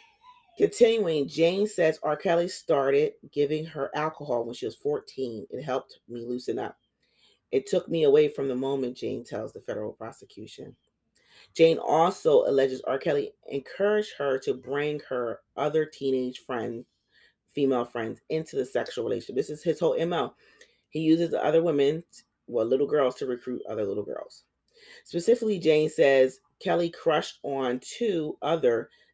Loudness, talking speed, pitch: -27 LUFS, 155 wpm, 160 Hz